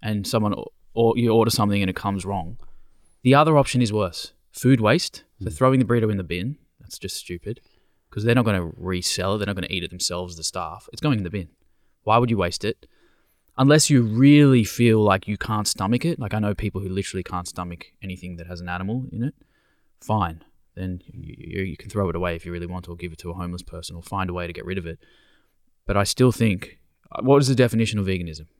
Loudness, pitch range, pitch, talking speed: -22 LUFS, 90-115 Hz, 100 Hz, 245 wpm